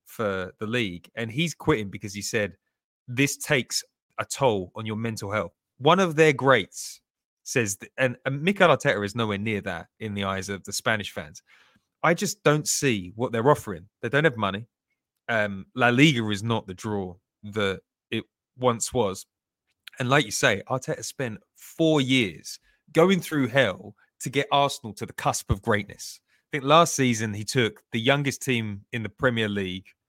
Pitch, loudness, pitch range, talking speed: 115 Hz, -25 LUFS, 105-140 Hz, 180 wpm